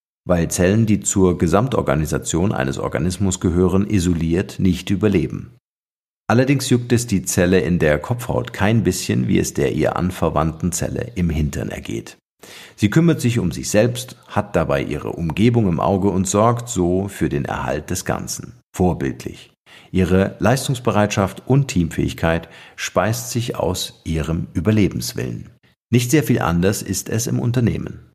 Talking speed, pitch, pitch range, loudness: 145 wpm, 100 Hz, 90-120 Hz, -19 LUFS